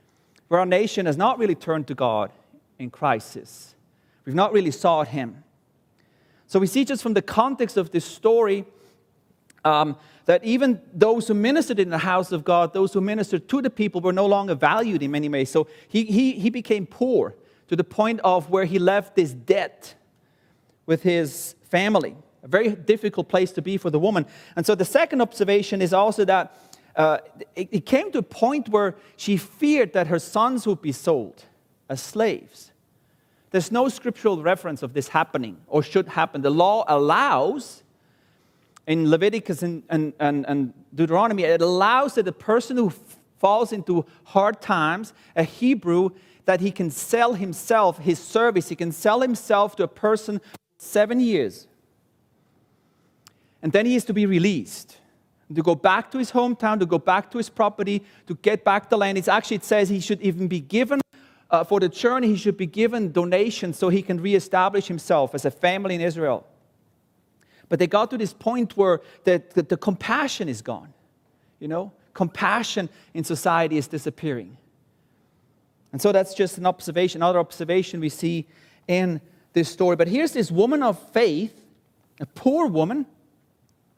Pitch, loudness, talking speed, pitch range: 185 Hz, -22 LUFS, 175 wpm, 165-215 Hz